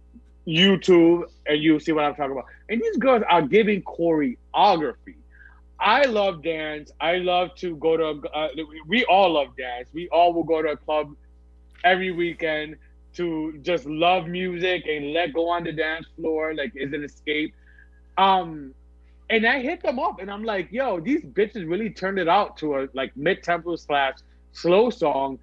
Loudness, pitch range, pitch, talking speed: -23 LUFS, 145-185 Hz, 165 Hz, 175 wpm